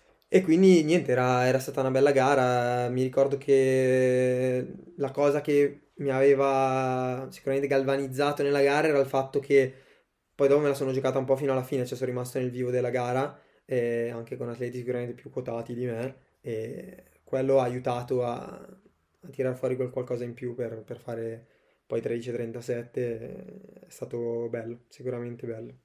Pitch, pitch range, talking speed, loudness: 130 Hz, 120-135 Hz, 170 wpm, -27 LUFS